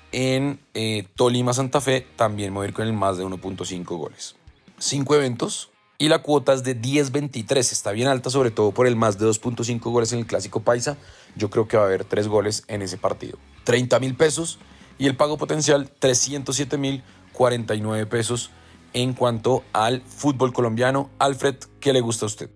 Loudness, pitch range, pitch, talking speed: -22 LUFS, 105-135 Hz, 125 Hz, 185 wpm